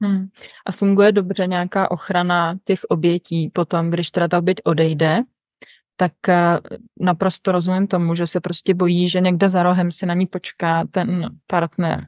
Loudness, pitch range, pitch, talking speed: -19 LUFS, 175-190 Hz, 180 Hz, 160 wpm